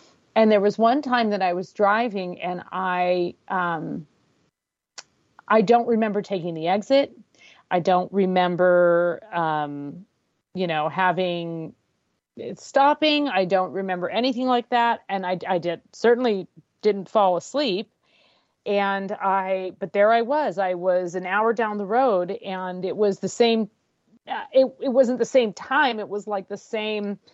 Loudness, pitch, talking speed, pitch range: -22 LUFS, 200 Hz, 155 wpm, 180-230 Hz